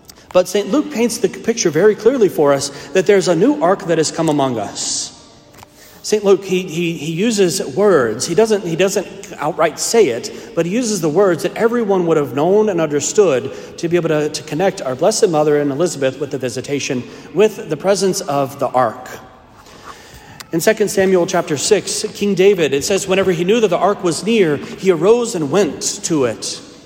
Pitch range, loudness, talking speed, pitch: 155-205 Hz, -16 LUFS, 200 wpm, 185 Hz